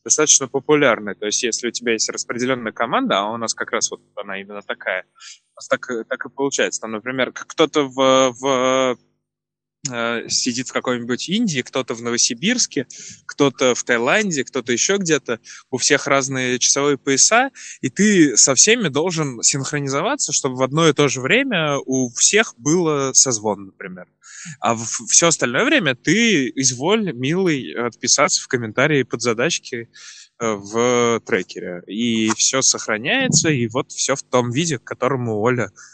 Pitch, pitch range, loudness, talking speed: 130 Hz, 120-145 Hz, -18 LUFS, 155 wpm